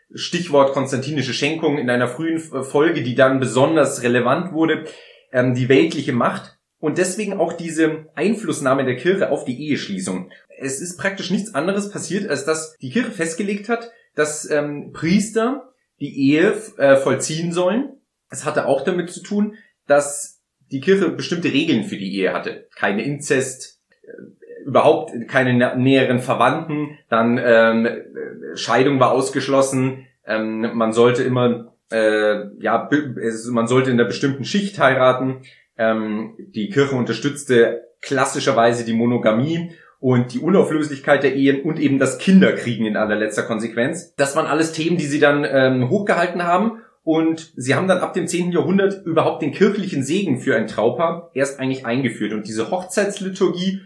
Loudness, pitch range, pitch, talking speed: -19 LUFS, 125-175 Hz, 145 Hz, 150 wpm